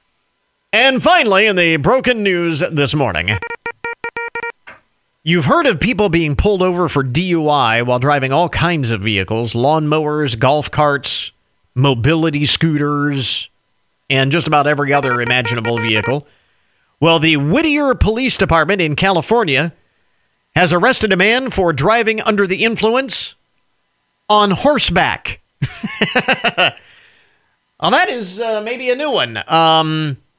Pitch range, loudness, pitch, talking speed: 145-220 Hz, -14 LUFS, 165 Hz, 125 wpm